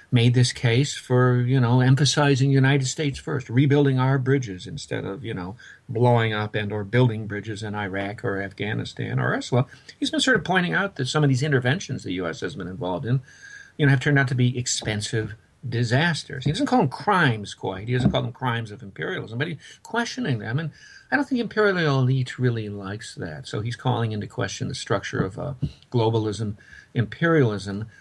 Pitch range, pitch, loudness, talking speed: 110-145 Hz, 130 Hz, -23 LUFS, 195 wpm